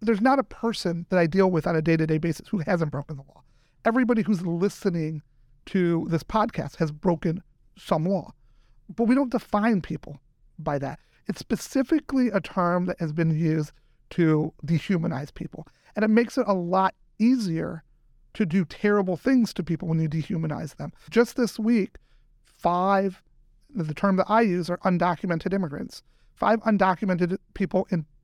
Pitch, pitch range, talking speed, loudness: 180 Hz, 160-205 Hz, 170 wpm, -25 LUFS